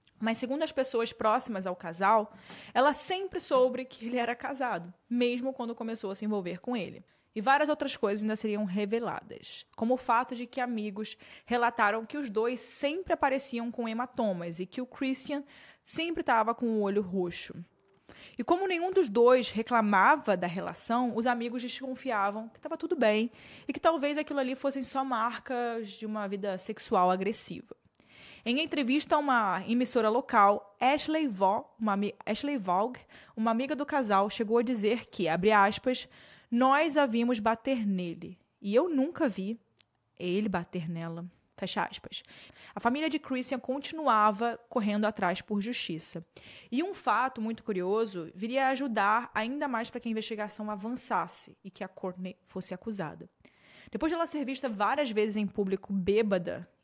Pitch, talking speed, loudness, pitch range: 230 Hz, 165 wpm, -30 LUFS, 205-260 Hz